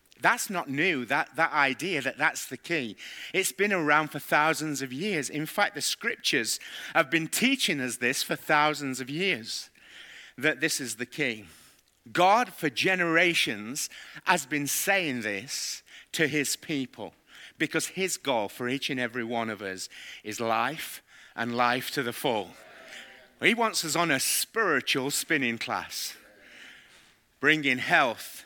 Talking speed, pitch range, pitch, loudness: 150 wpm, 125-170 Hz, 150 Hz, -27 LUFS